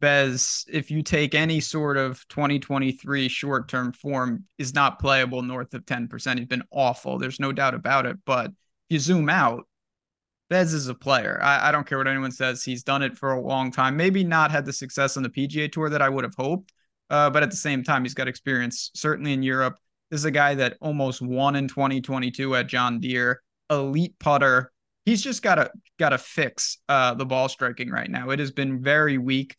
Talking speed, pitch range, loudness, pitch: 210 wpm, 130-150 Hz, -24 LUFS, 135 Hz